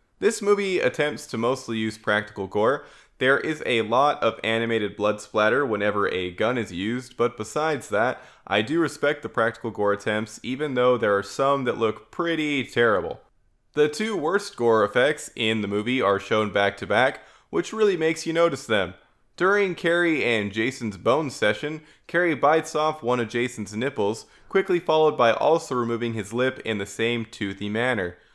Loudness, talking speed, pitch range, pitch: -24 LUFS, 180 wpm, 110-155 Hz, 120 Hz